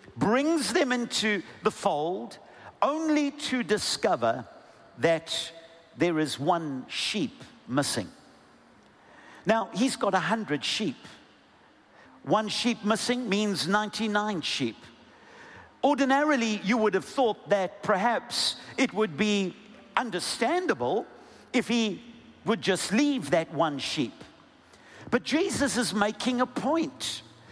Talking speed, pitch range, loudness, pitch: 110 wpm, 185-255 Hz, -27 LUFS, 220 Hz